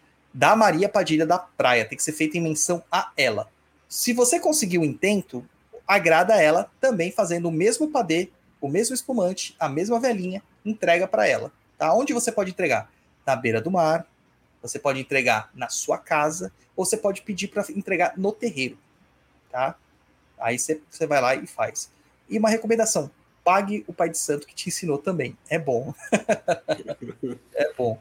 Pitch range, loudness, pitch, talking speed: 150-210 Hz, -23 LUFS, 175 Hz, 175 wpm